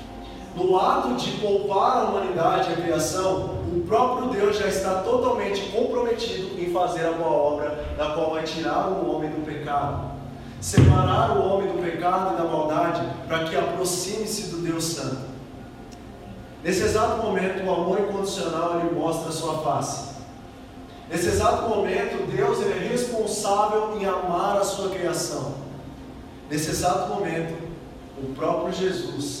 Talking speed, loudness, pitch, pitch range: 145 wpm, -24 LUFS, 170 Hz, 155-195 Hz